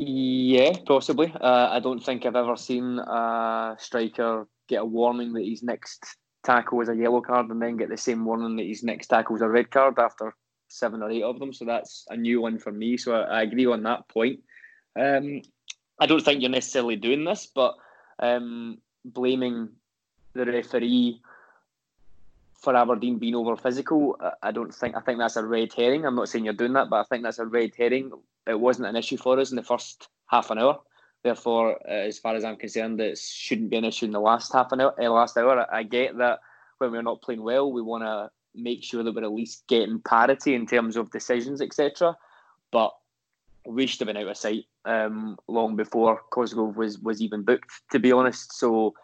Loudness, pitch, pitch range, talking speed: -25 LUFS, 120 Hz, 115-125 Hz, 210 wpm